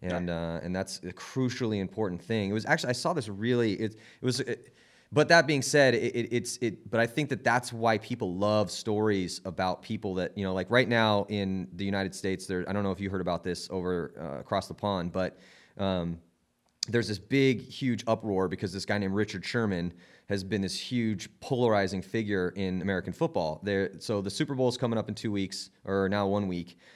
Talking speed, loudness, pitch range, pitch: 220 wpm, -30 LUFS, 95-115 Hz, 100 Hz